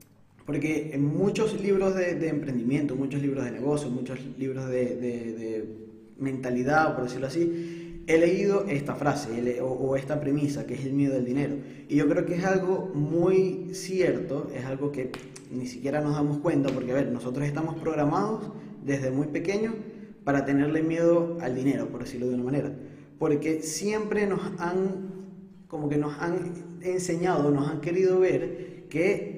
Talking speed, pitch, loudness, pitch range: 170 wpm, 150 Hz, -28 LUFS, 135-175 Hz